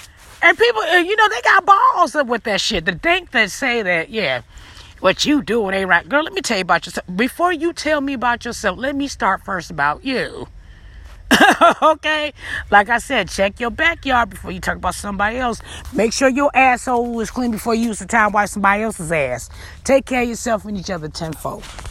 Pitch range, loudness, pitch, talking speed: 195-280 Hz, -17 LUFS, 235 Hz, 210 wpm